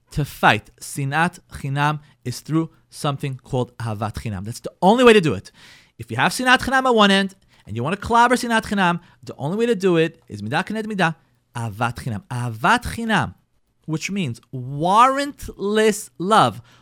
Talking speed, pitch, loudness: 170 wpm, 160 Hz, -20 LUFS